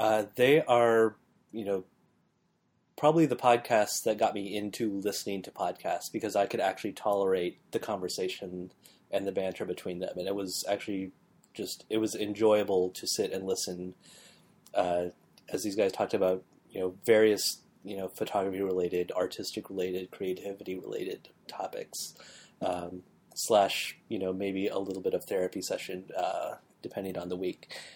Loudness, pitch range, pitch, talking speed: -31 LUFS, 90-105 Hz, 100 Hz, 155 wpm